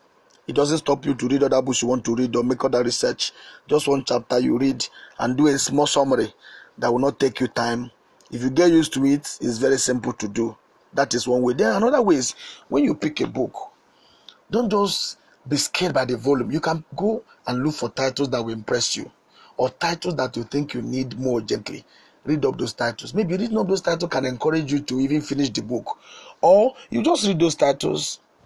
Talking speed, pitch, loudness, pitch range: 225 wpm, 140 Hz, -22 LUFS, 125-160 Hz